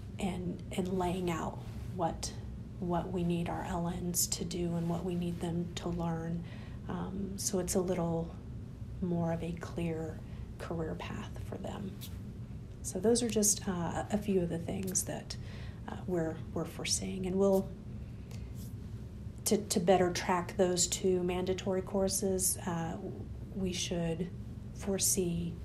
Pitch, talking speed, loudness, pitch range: 175 Hz, 145 wpm, -34 LUFS, 115-185 Hz